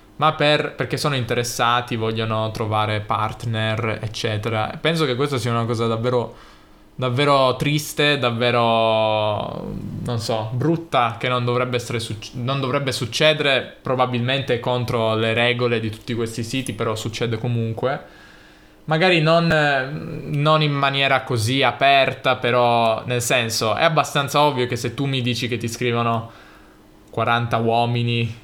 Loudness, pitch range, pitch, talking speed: -20 LUFS, 115-135 Hz, 120 Hz, 135 wpm